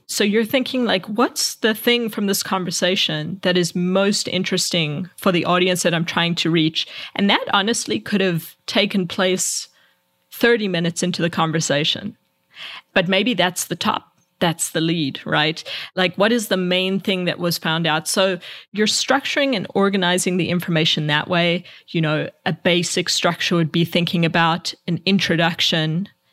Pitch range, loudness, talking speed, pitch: 170-200 Hz, -19 LUFS, 165 wpm, 180 Hz